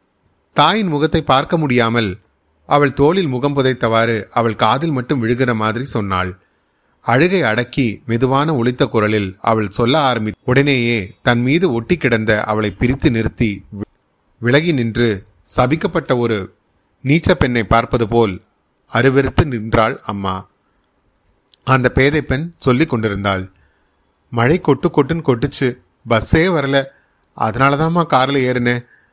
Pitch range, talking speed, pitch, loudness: 105-140 Hz, 110 wpm, 120 Hz, -16 LUFS